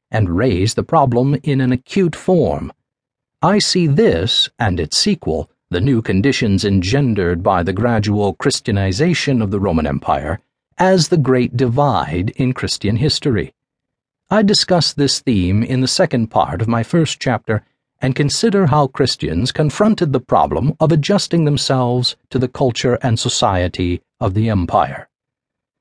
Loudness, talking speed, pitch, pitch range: -16 LUFS, 145 wpm, 130 Hz, 110-150 Hz